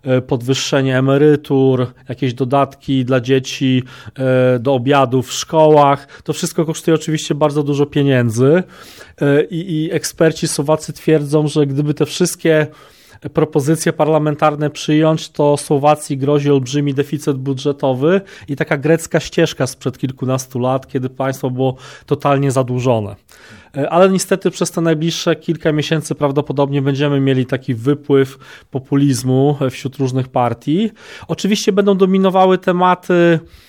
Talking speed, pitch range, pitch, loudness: 120 wpm, 135-160 Hz, 145 Hz, -15 LUFS